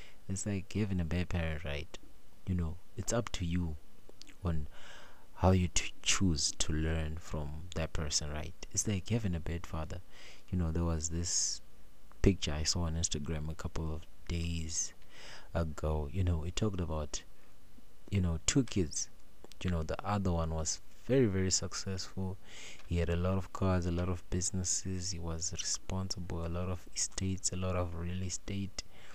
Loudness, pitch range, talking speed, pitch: -35 LUFS, 80-95 Hz, 175 wpm, 90 Hz